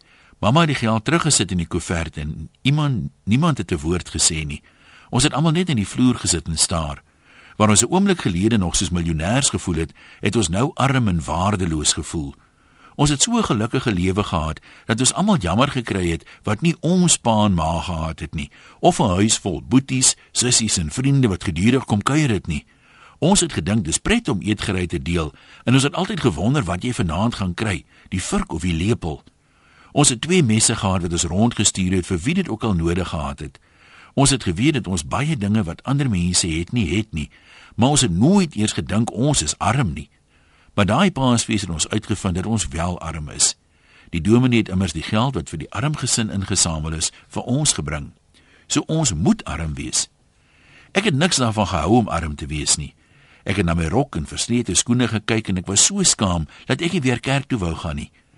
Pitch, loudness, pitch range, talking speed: 105 Hz, -19 LUFS, 85-125 Hz, 210 wpm